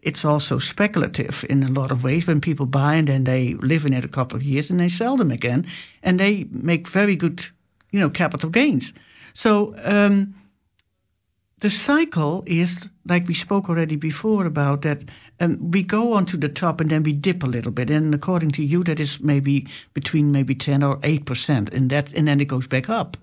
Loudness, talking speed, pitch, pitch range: -21 LUFS, 210 wpm, 150 Hz, 140-180 Hz